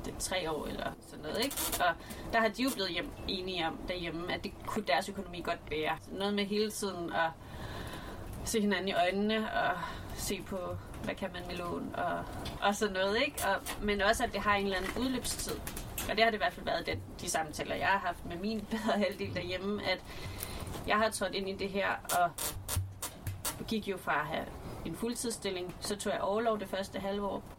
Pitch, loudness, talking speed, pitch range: 195 Hz, -34 LUFS, 215 wpm, 175-215 Hz